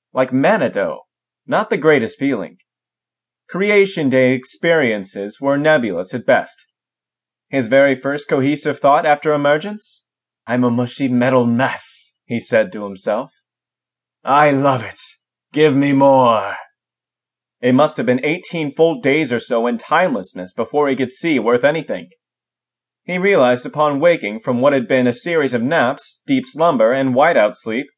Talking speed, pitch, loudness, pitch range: 150 wpm, 140 Hz, -16 LUFS, 125-155 Hz